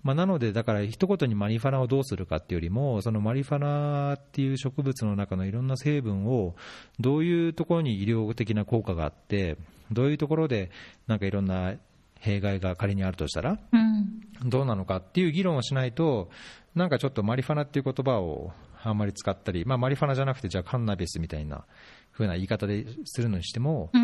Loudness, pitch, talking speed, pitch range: -28 LUFS, 115 Hz, 430 characters per minute, 100-140 Hz